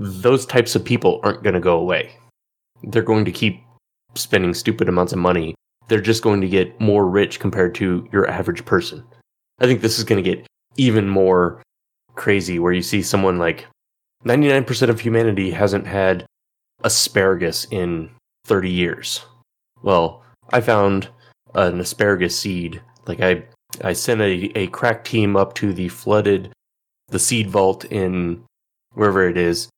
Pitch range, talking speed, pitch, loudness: 90-110 Hz, 155 wpm, 100 Hz, -19 LUFS